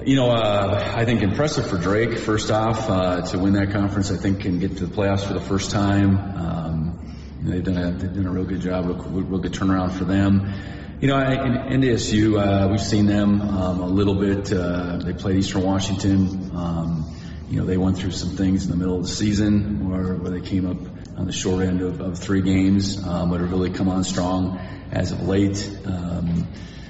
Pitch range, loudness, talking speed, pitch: 90-100 Hz, -22 LUFS, 225 wpm, 95 Hz